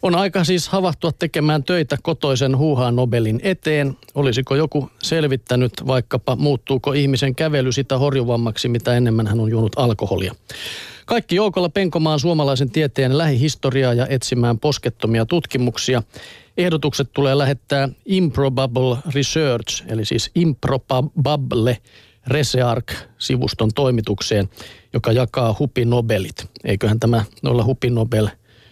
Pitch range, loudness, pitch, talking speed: 115-150 Hz, -19 LUFS, 130 Hz, 115 wpm